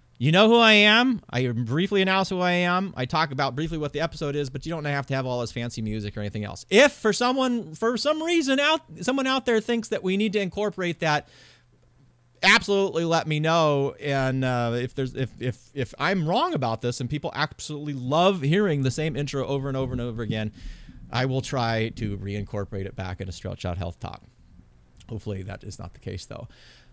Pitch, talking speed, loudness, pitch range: 140 Hz, 220 wpm, -24 LUFS, 120-185 Hz